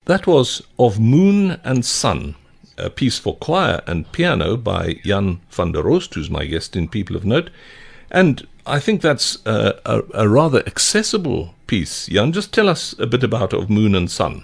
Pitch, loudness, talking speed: 120 Hz, -18 LUFS, 185 wpm